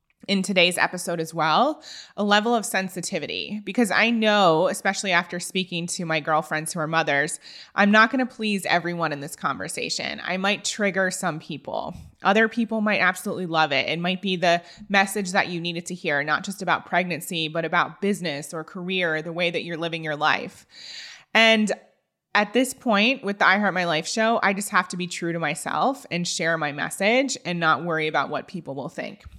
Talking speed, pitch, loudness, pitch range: 200 wpm, 180 Hz, -23 LUFS, 165-200 Hz